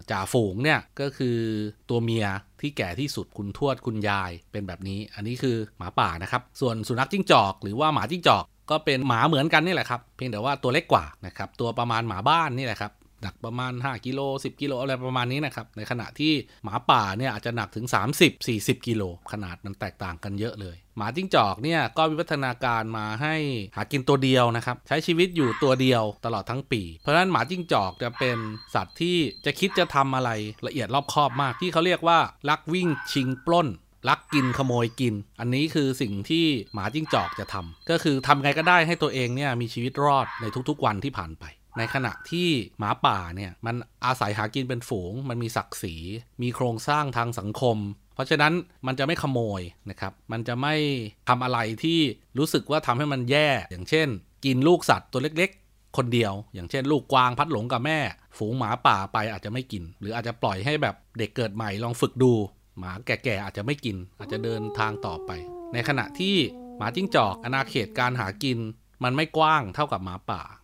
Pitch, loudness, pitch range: 125 Hz, -25 LUFS, 105-145 Hz